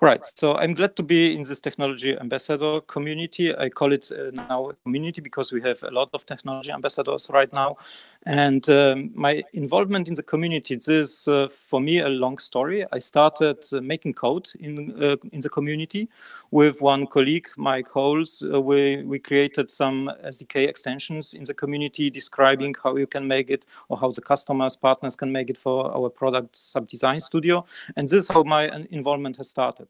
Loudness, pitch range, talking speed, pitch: -23 LUFS, 135-155 Hz, 190 wpm, 140 Hz